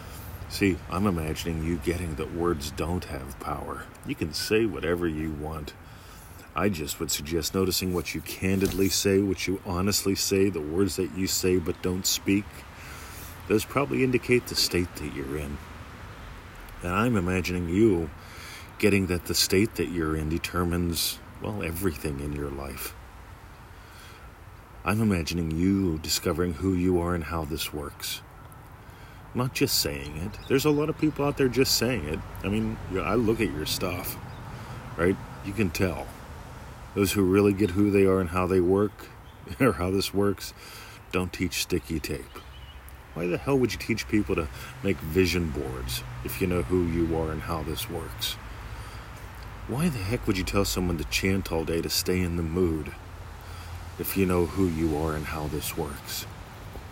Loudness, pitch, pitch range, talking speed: -27 LUFS, 90 Hz, 85-100 Hz, 175 wpm